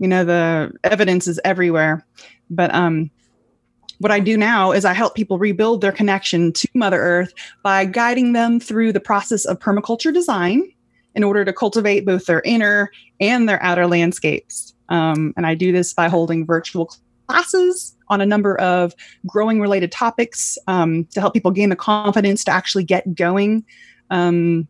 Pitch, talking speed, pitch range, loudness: 195 Hz, 170 wpm, 175-215 Hz, -17 LUFS